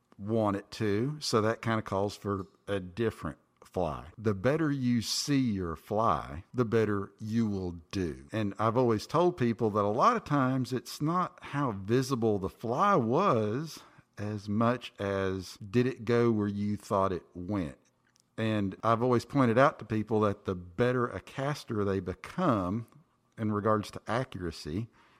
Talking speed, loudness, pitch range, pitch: 165 wpm, -30 LUFS, 100-120 Hz, 110 Hz